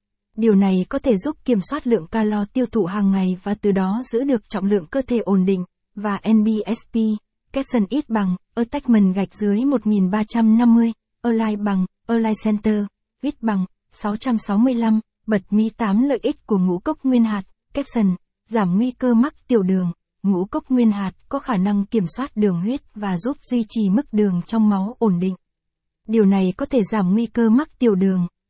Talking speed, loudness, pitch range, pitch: 185 wpm, -20 LUFS, 200-240 Hz, 215 Hz